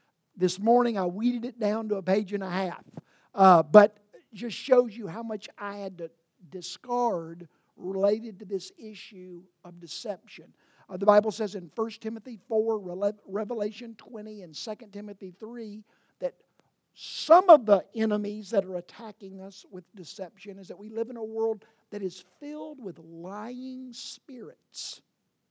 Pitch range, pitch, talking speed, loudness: 190-225 Hz, 210 Hz, 160 wpm, -27 LUFS